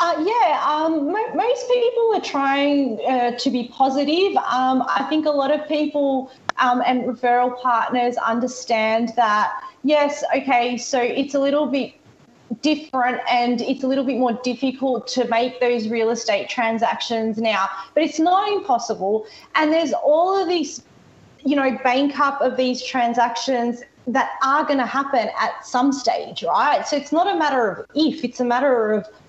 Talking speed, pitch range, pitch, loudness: 170 wpm, 240-295 Hz, 260 Hz, -20 LUFS